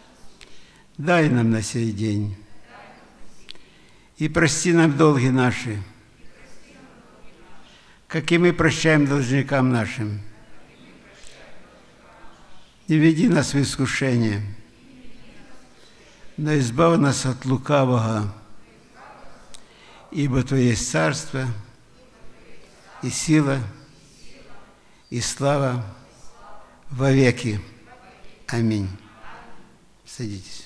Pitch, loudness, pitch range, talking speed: 130 Hz, -21 LUFS, 110-155 Hz, 75 wpm